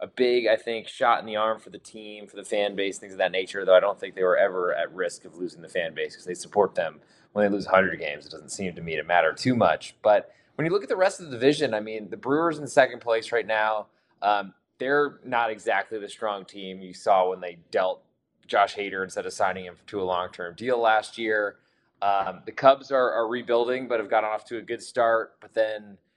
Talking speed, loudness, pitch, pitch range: 255 wpm, -25 LUFS, 110 Hz, 100-125 Hz